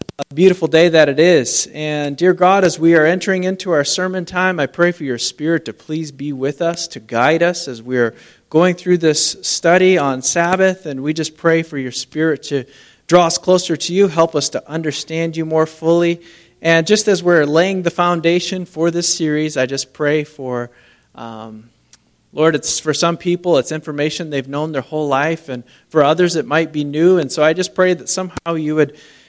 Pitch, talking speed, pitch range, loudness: 160 Hz, 205 wpm, 145-175 Hz, -16 LUFS